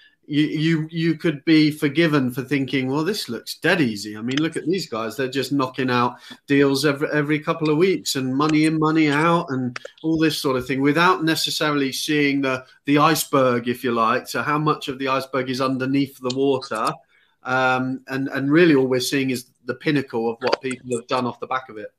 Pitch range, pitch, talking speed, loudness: 130-155 Hz, 140 Hz, 215 wpm, -21 LUFS